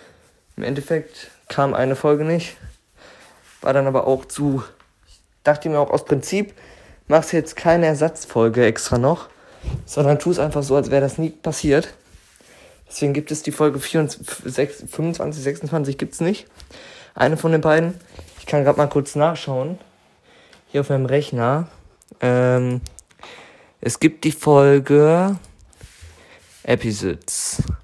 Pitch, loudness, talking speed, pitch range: 145 Hz, -19 LUFS, 135 wpm, 130-160 Hz